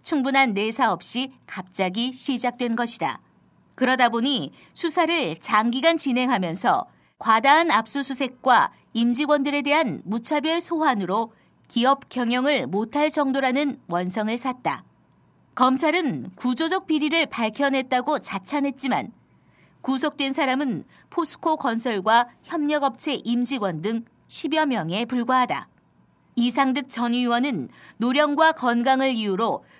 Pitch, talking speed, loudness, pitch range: 260 Hz, 265 characters per minute, -22 LUFS, 235-290 Hz